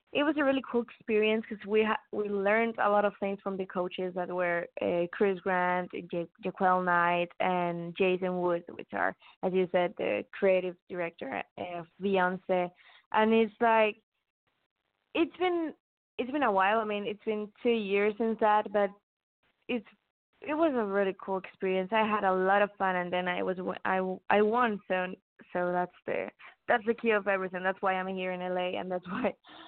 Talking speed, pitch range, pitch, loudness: 195 wpm, 180-220 Hz, 195 Hz, -30 LUFS